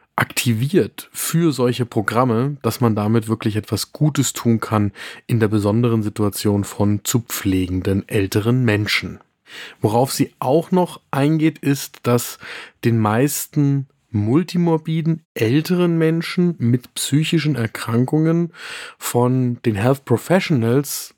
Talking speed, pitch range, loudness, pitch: 115 wpm, 110-155 Hz, -19 LUFS, 125 Hz